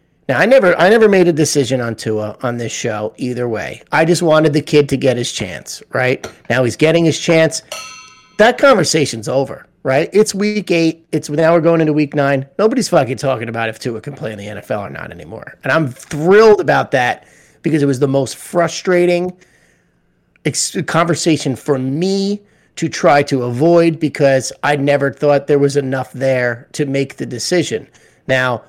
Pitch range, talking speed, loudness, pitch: 130-170 Hz, 185 wpm, -15 LUFS, 145 Hz